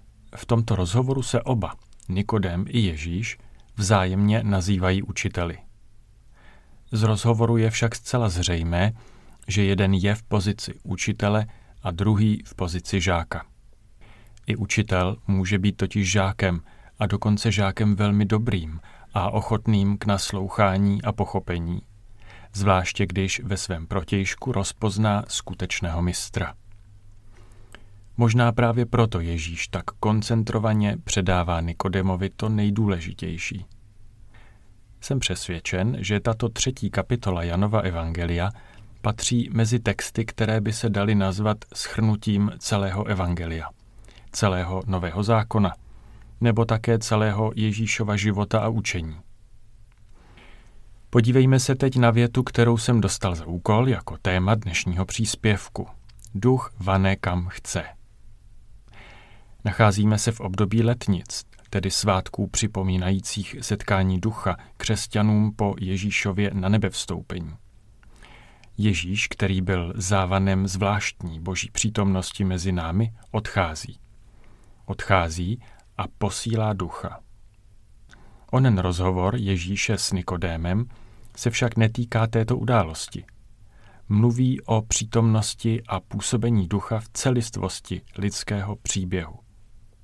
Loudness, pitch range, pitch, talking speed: -24 LUFS, 95-110 Hz, 105 Hz, 105 wpm